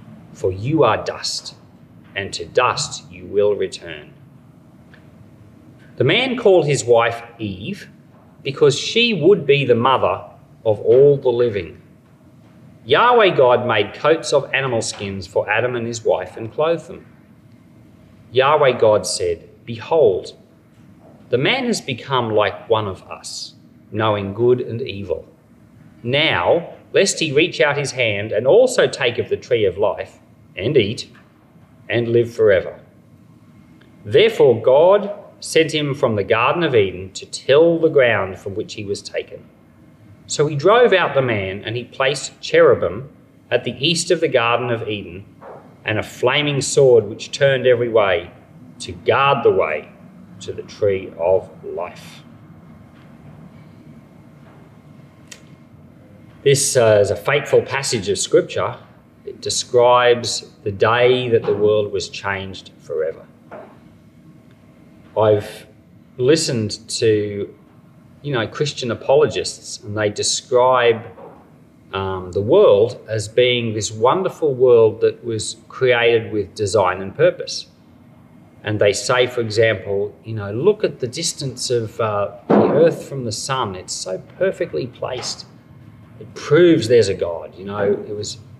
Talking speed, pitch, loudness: 135 wpm, 130 Hz, -17 LUFS